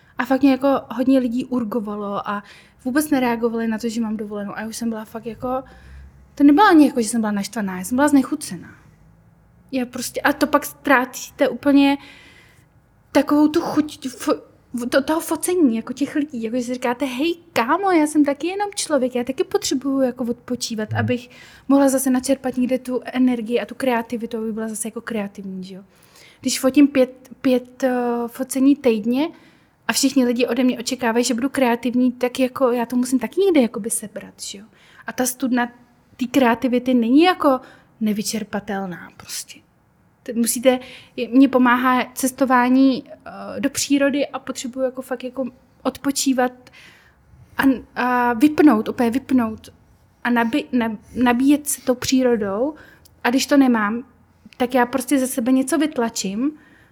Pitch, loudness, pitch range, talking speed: 255 Hz, -20 LUFS, 235-275 Hz, 160 wpm